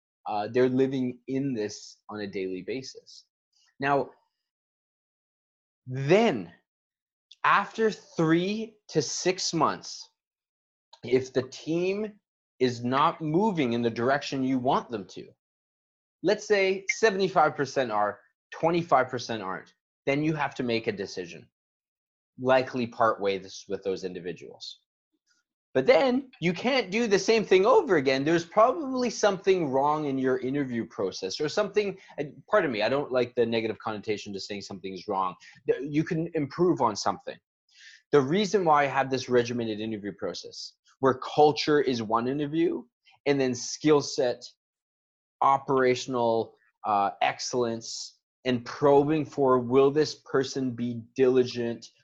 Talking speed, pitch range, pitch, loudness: 135 wpm, 120-190 Hz, 135 Hz, -27 LUFS